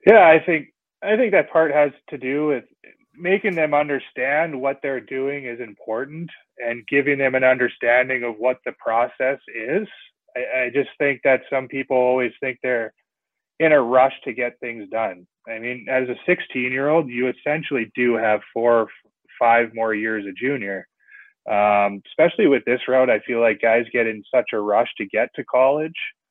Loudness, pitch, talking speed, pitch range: -20 LUFS, 130 Hz, 185 wpm, 120-145 Hz